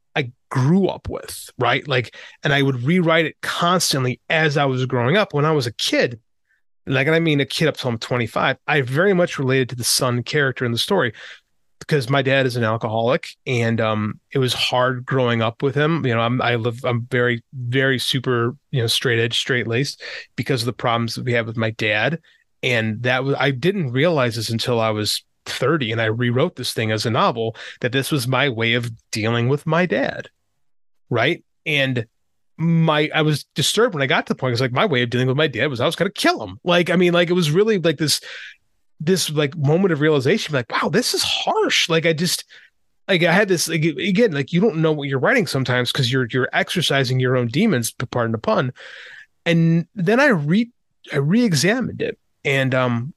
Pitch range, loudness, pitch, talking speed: 120-165 Hz, -19 LUFS, 135 Hz, 220 wpm